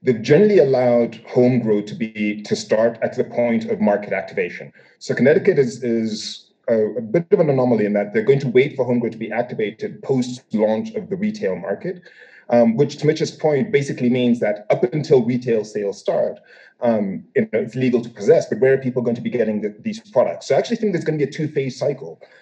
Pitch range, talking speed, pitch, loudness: 115-155 Hz, 230 wpm, 125 Hz, -19 LUFS